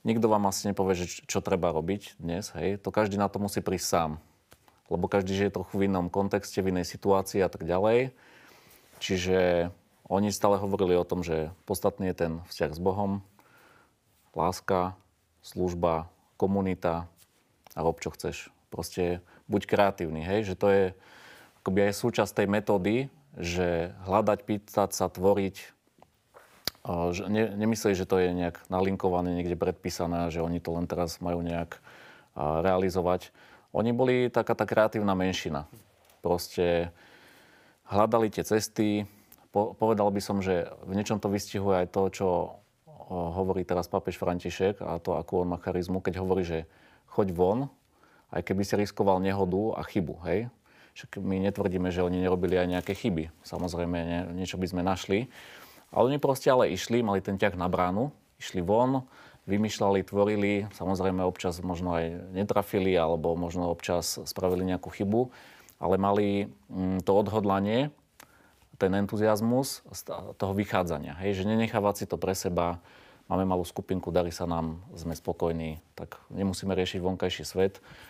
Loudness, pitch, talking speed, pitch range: -29 LUFS, 95 Hz, 150 wpm, 90-100 Hz